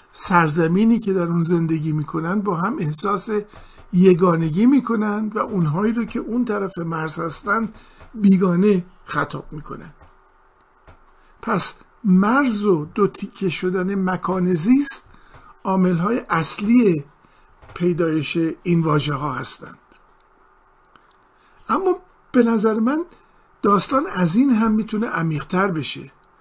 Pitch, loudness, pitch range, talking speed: 190 Hz, -19 LUFS, 170-220 Hz, 115 wpm